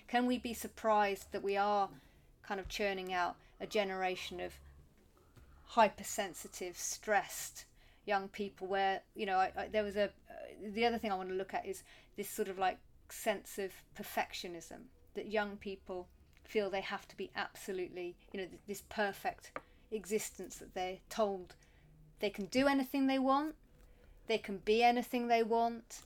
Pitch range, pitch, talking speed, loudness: 190-220 Hz, 205 Hz, 170 wpm, -37 LUFS